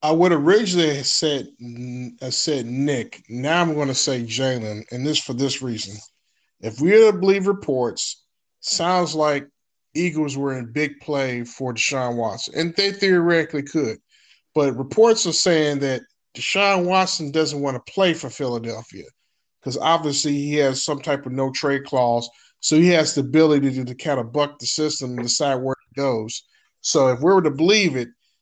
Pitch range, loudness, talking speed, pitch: 130-160 Hz, -20 LUFS, 180 wpm, 145 Hz